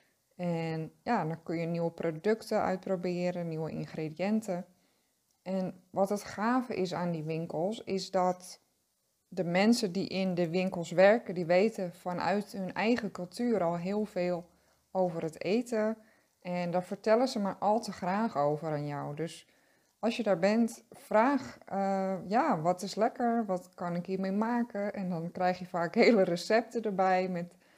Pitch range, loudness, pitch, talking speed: 175-210 Hz, -31 LUFS, 185 Hz, 160 wpm